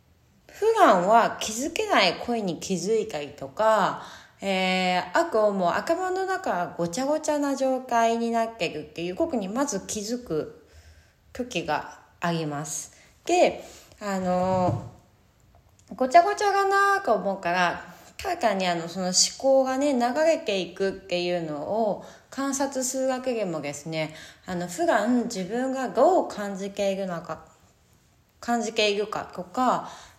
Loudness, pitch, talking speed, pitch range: -25 LUFS, 210 Hz, 265 characters per minute, 175-260 Hz